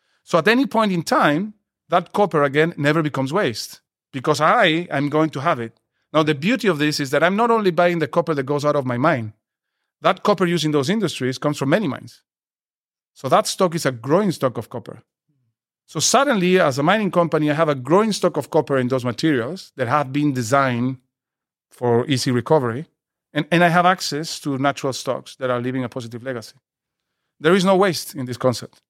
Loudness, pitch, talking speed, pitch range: -19 LUFS, 150 Hz, 210 wpm, 130-175 Hz